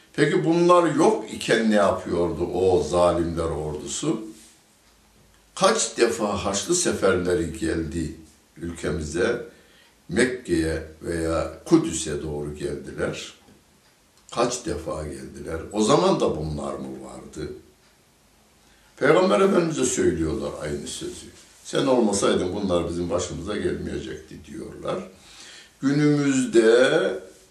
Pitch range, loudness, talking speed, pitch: 75-110 Hz, -23 LUFS, 90 wpm, 85 Hz